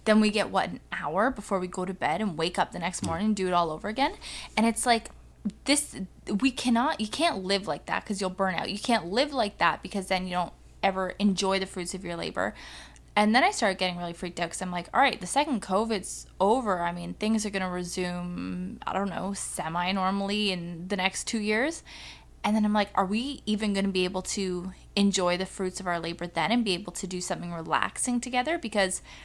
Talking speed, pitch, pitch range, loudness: 240 wpm, 195 Hz, 180-215 Hz, -28 LUFS